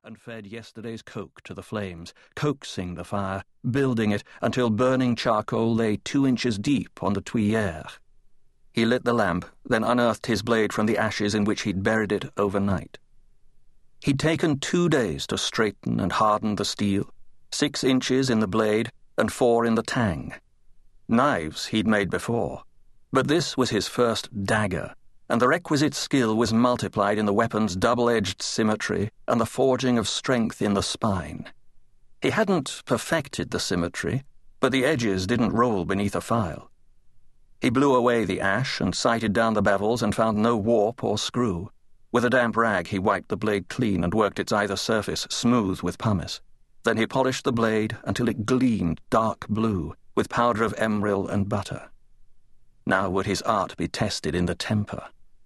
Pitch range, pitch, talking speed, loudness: 100-120 Hz, 110 Hz, 170 wpm, -24 LUFS